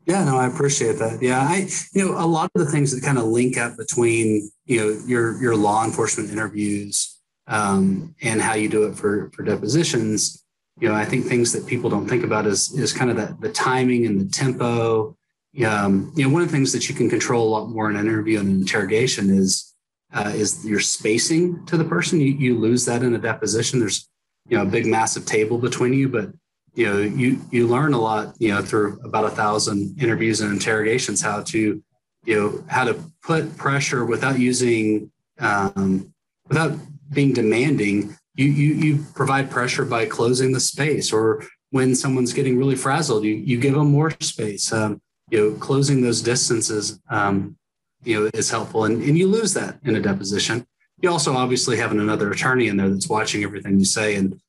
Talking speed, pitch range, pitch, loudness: 205 wpm, 110-140 Hz, 120 Hz, -20 LUFS